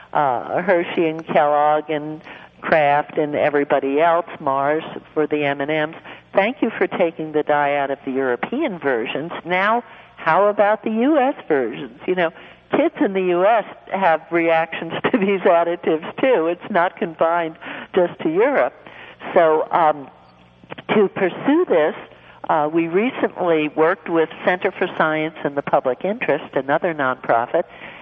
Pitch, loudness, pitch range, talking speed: 170 Hz, -19 LUFS, 155-200 Hz, 145 wpm